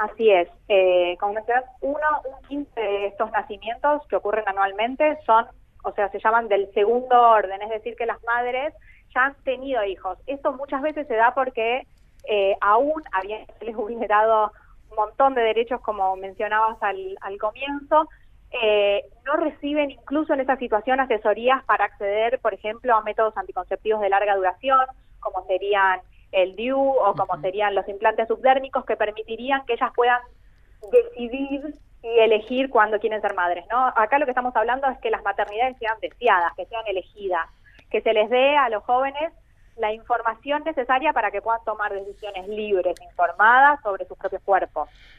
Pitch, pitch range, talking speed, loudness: 220 Hz, 200-260 Hz, 165 wpm, -22 LUFS